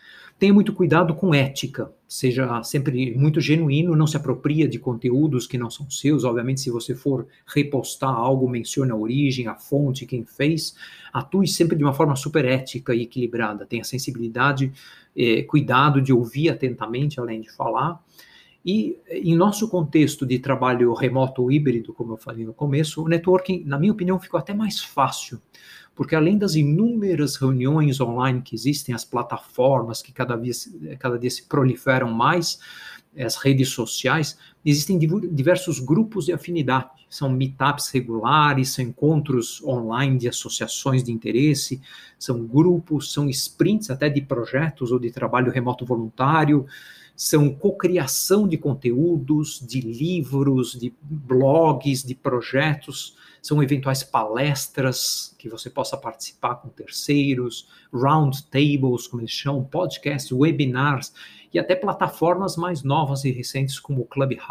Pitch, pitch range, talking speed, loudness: 140 Hz, 125-155 Hz, 145 wpm, -22 LUFS